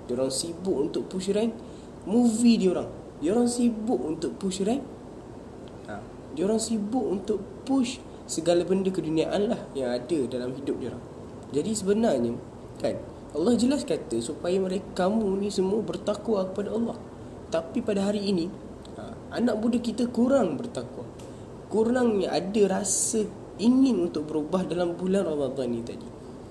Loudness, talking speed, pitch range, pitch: -27 LUFS, 150 wpm, 165-225 Hz, 195 Hz